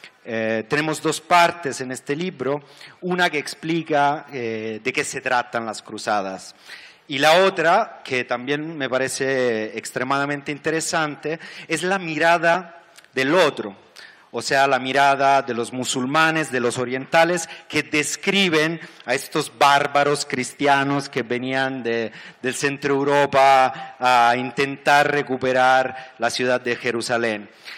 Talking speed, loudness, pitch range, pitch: 130 wpm, -20 LUFS, 125-155 Hz, 140 Hz